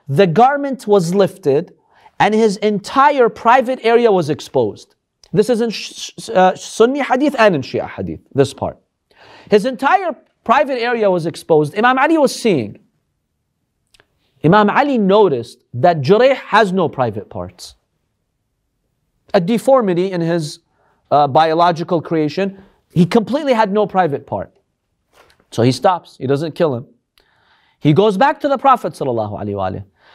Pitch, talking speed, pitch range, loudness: 195 Hz, 135 wpm, 160-245 Hz, -15 LUFS